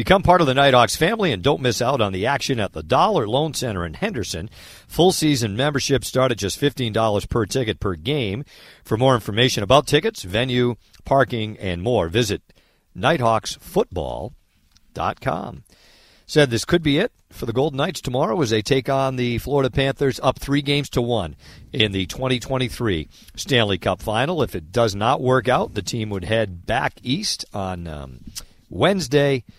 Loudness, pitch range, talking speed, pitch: -20 LUFS, 105-140 Hz, 170 wpm, 125 Hz